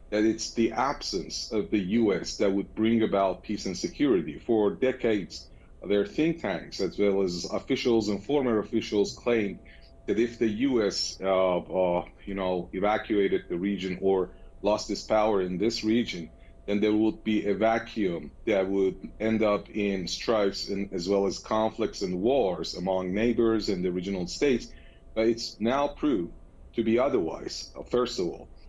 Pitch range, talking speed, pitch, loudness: 95-110 Hz, 165 wpm, 100 Hz, -28 LUFS